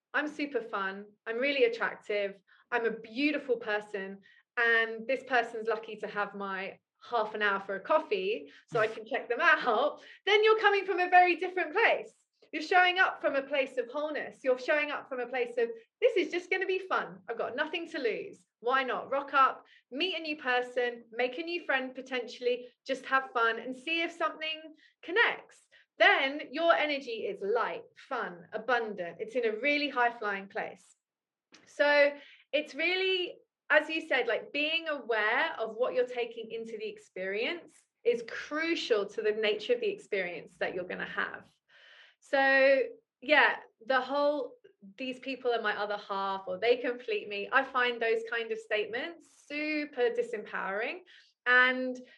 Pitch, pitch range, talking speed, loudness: 275 Hz, 230-345 Hz, 175 wpm, -30 LUFS